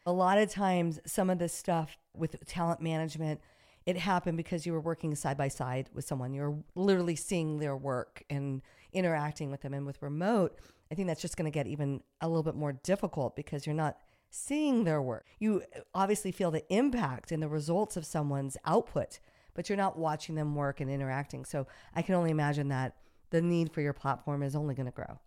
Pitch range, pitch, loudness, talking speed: 145-175 Hz, 155 Hz, -33 LUFS, 205 wpm